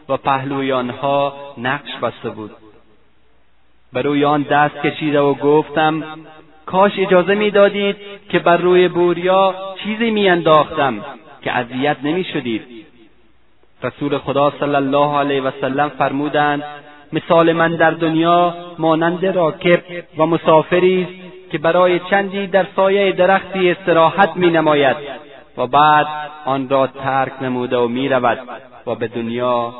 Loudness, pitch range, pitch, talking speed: -16 LUFS, 140-180 Hz, 155 Hz, 125 wpm